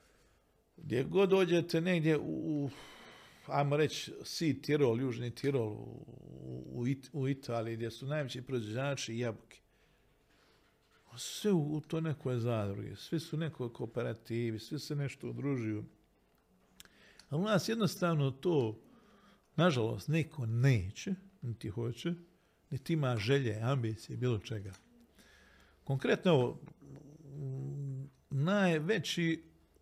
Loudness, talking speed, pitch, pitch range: -35 LUFS, 110 wpm, 140 Hz, 120-160 Hz